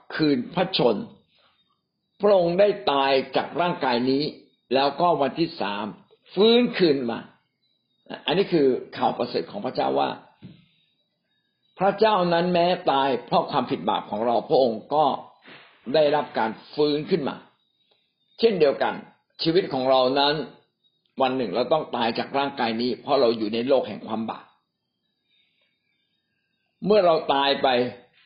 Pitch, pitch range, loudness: 160 Hz, 135-190 Hz, -23 LUFS